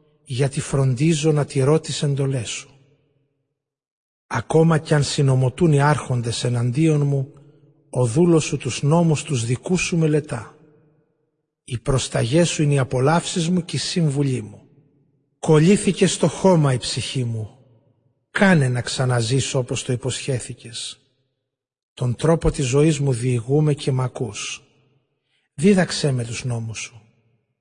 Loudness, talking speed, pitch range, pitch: -20 LUFS, 130 wpm, 130-155 Hz, 140 Hz